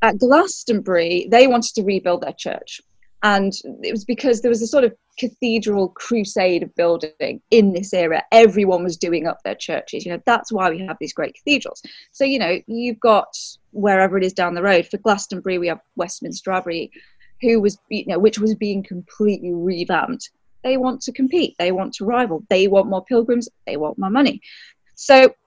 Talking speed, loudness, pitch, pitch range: 195 wpm, -19 LUFS, 210 Hz, 185-240 Hz